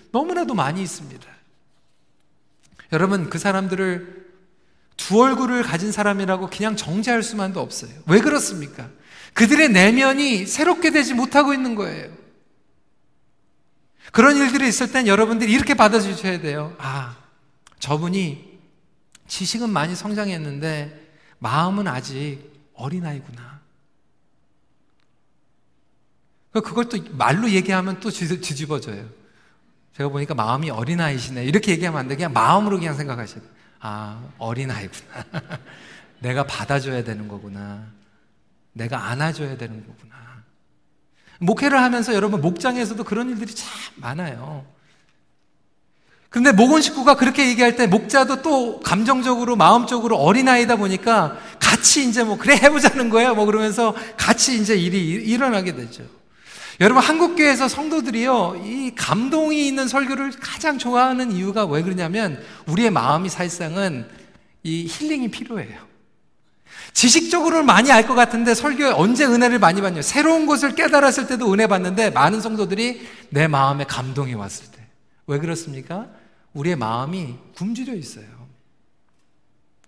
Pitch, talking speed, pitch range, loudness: 195 Hz, 310 characters per minute, 145-240 Hz, -18 LUFS